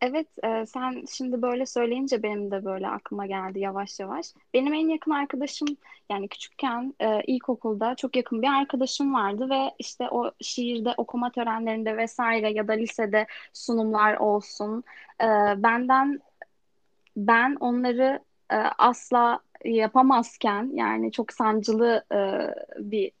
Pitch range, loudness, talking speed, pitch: 215-265 Hz, -26 LUFS, 130 wpm, 235 Hz